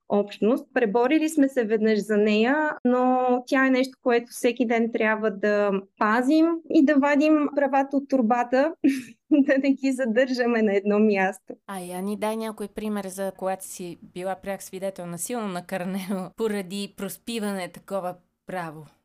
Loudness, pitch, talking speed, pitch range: -24 LUFS, 220 Hz, 155 wpm, 195-260 Hz